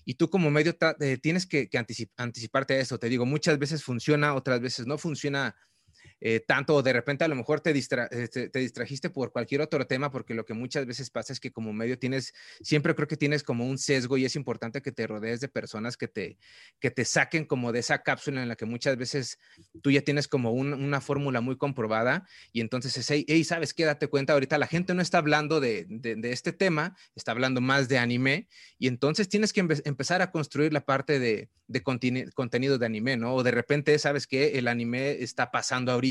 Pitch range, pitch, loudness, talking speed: 125-150 Hz, 135 Hz, -28 LUFS, 225 wpm